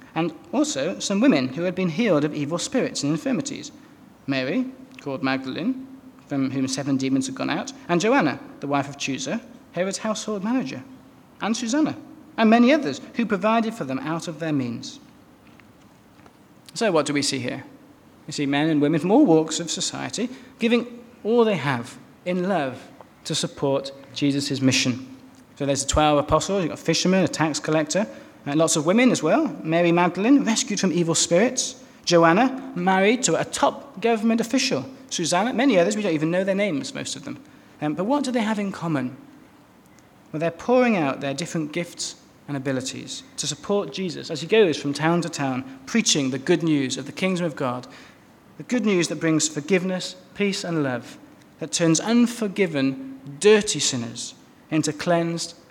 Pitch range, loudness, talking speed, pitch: 145-235 Hz, -23 LUFS, 180 wpm, 175 Hz